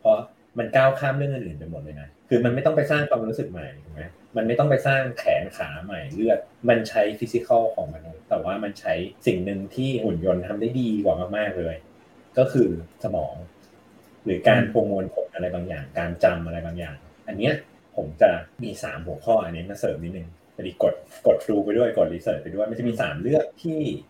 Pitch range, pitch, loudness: 85-130 Hz, 105 Hz, -24 LUFS